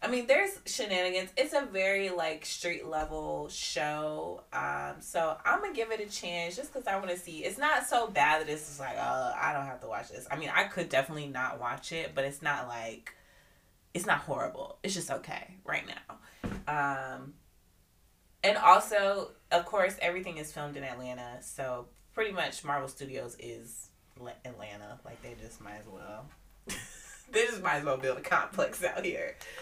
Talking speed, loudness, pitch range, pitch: 190 wpm, -32 LUFS, 125-185 Hz, 150 Hz